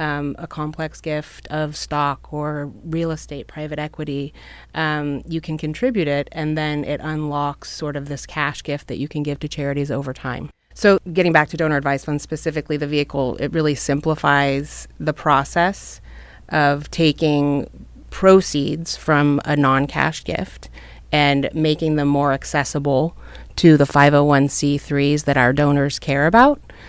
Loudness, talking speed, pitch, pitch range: -19 LUFS, 155 wpm, 150 Hz, 140-155 Hz